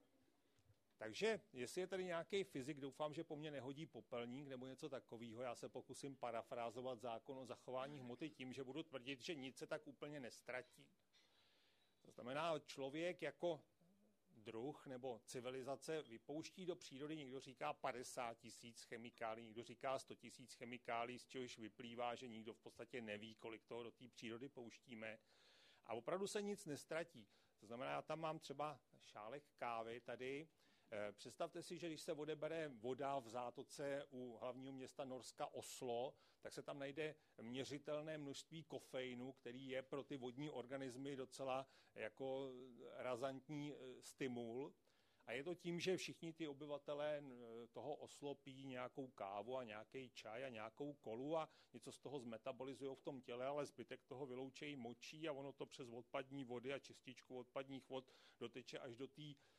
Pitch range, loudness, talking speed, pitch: 120-145 Hz, -52 LUFS, 160 wpm, 135 Hz